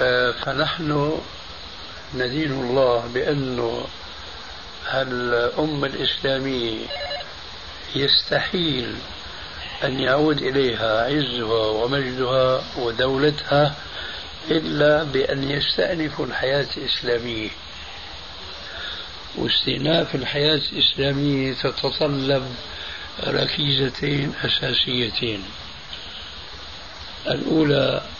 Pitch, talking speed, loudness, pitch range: 130 Hz, 55 wpm, -22 LUFS, 110-145 Hz